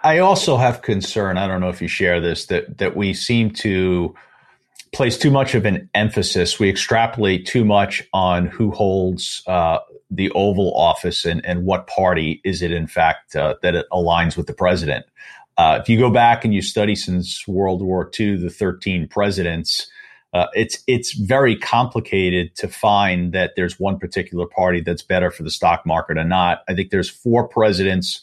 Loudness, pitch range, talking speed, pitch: -18 LUFS, 90-110 Hz, 185 wpm, 95 Hz